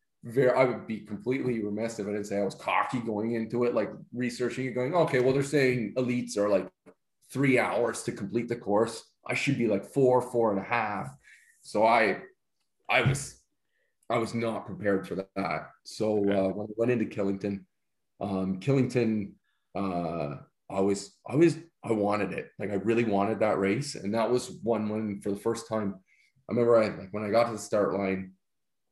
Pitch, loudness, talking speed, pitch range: 110 Hz, -29 LUFS, 195 wpm, 100-120 Hz